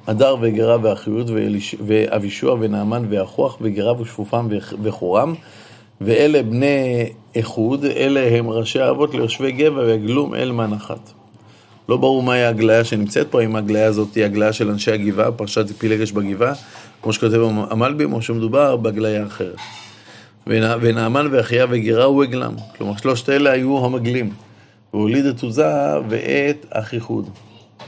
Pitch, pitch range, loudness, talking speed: 115 Hz, 110-125 Hz, -18 LUFS, 130 wpm